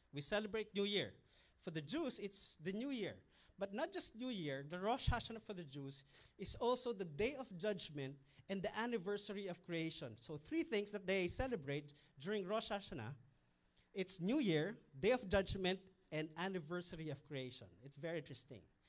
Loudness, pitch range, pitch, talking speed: -44 LUFS, 145-210 Hz, 185 Hz, 175 wpm